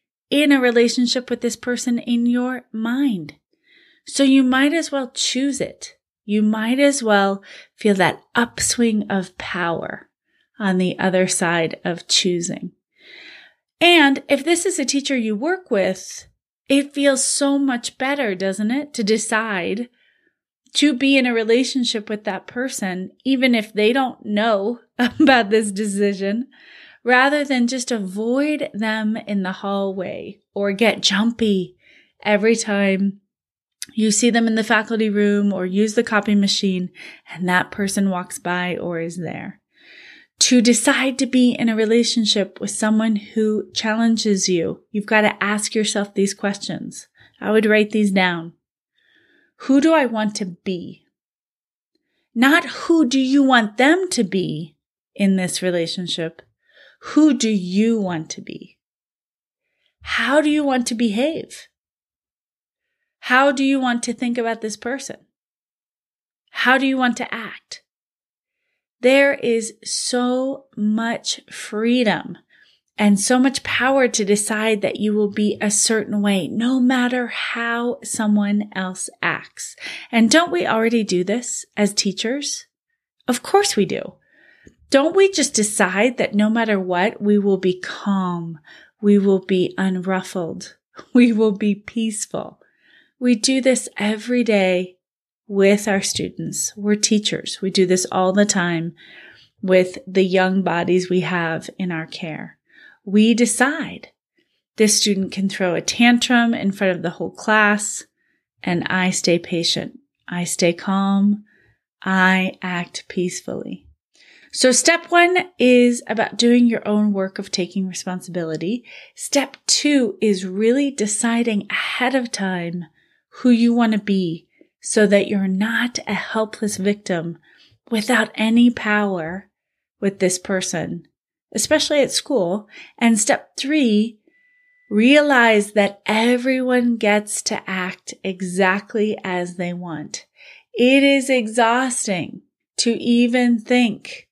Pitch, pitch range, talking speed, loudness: 220 Hz, 195-250 Hz, 140 wpm, -19 LUFS